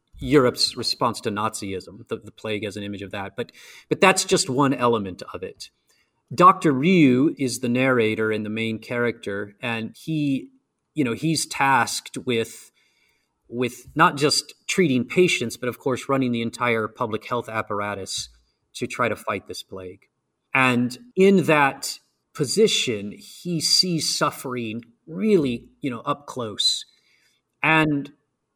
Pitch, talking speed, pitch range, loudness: 125 Hz, 145 wpm, 110-150 Hz, -22 LUFS